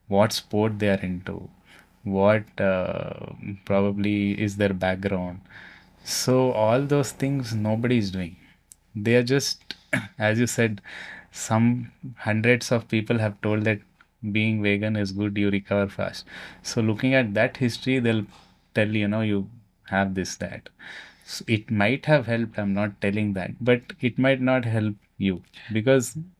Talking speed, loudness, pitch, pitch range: 150 wpm, -24 LUFS, 110 Hz, 100-120 Hz